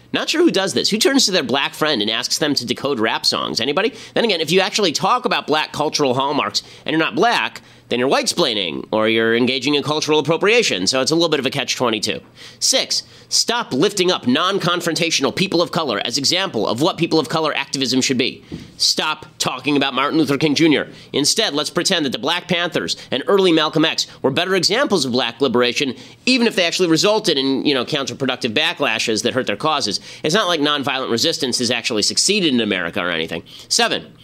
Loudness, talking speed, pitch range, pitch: -17 LUFS, 210 wpm, 130-175 Hz, 150 Hz